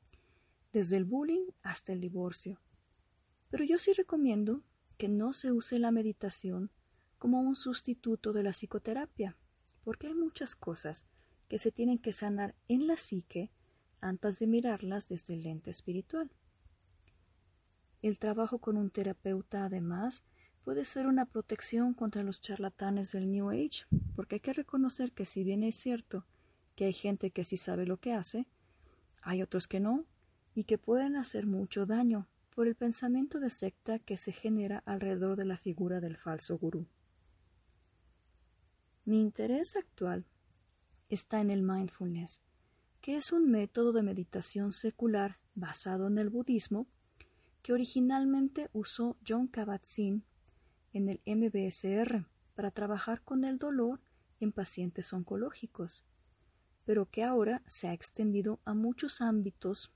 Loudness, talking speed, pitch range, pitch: -35 LUFS, 145 wpm, 185-235 Hz, 205 Hz